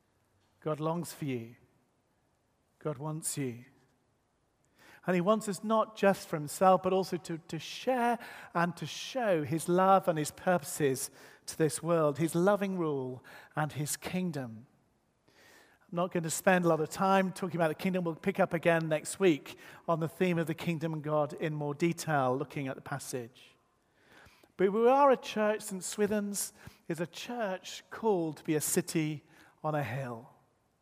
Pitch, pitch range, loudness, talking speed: 165 Hz, 145-185 Hz, -32 LUFS, 175 wpm